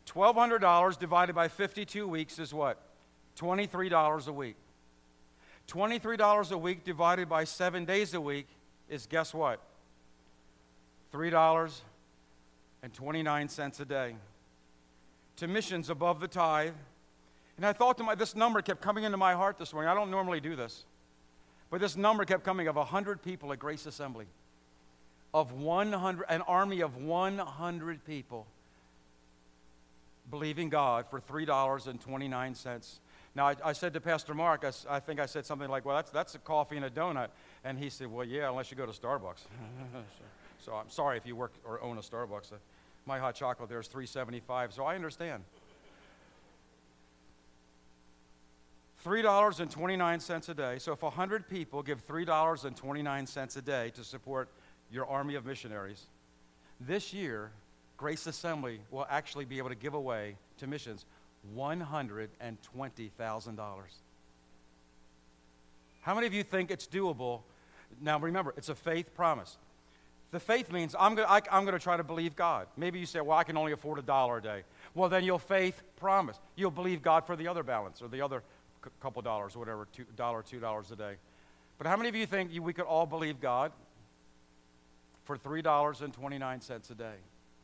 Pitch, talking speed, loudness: 140 Hz, 165 wpm, -33 LUFS